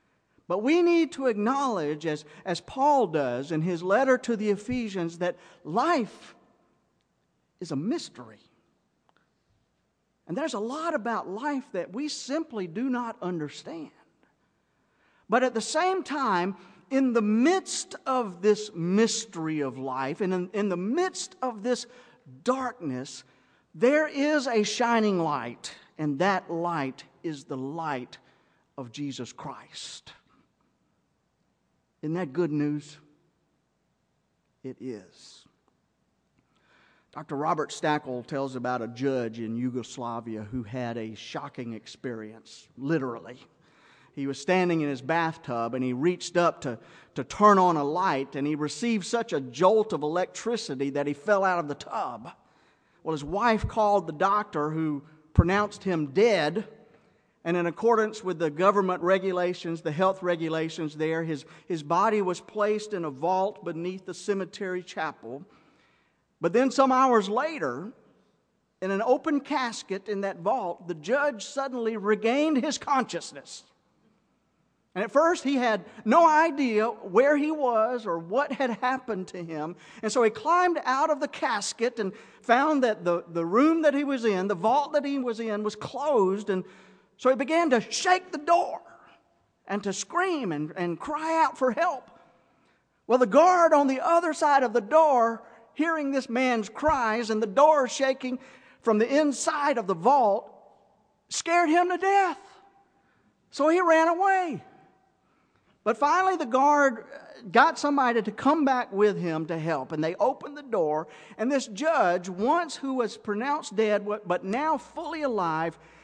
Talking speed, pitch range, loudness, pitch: 150 wpm, 170-270 Hz, -26 LUFS, 215 Hz